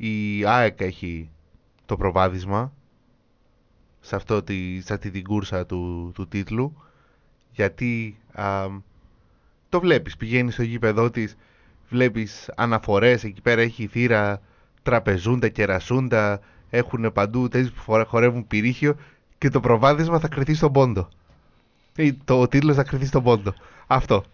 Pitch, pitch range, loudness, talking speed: 110 Hz, 100-125 Hz, -22 LUFS, 135 wpm